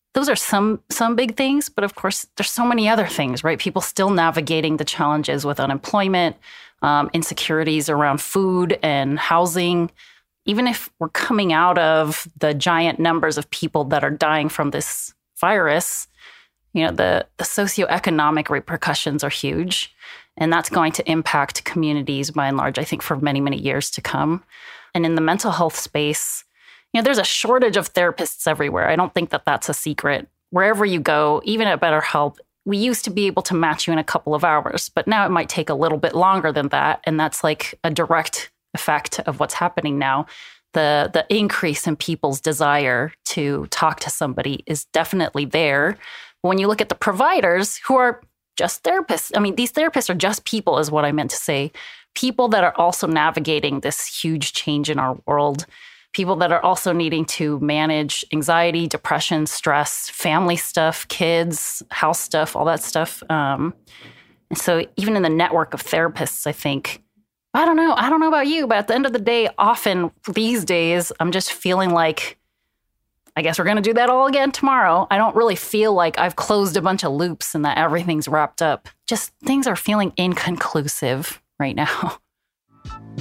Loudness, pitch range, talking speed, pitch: -19 LUFS, 155-205 Hz, 190 wpm, 165 Hz